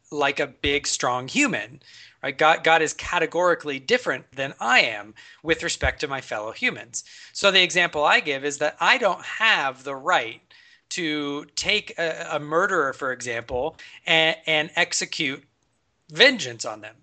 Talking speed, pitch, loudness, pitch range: 160 wpm, 150 Hz, -22 LUFS, 135-170 Hz